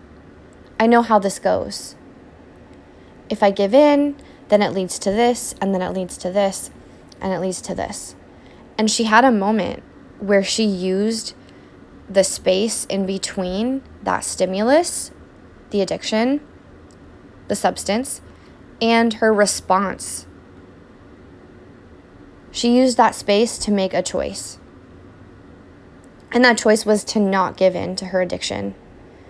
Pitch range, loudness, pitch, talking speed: 180-220 Hz, -19 LUFS, 195 Hz, 135 wpm